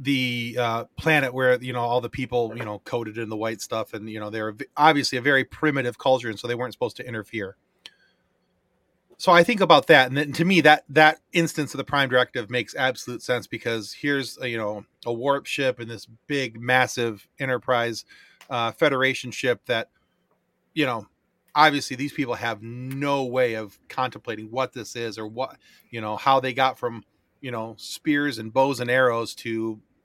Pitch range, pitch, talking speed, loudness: 115-140 Hz, 125 Hz, 195 wpm, -23 LUFS